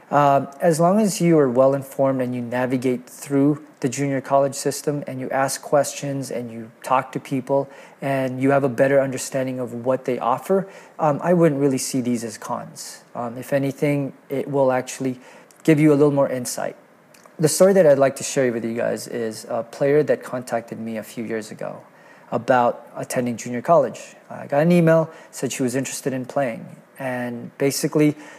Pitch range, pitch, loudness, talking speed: 125-145 Hz, 135 Hz, -21 LUFS, 190 wpm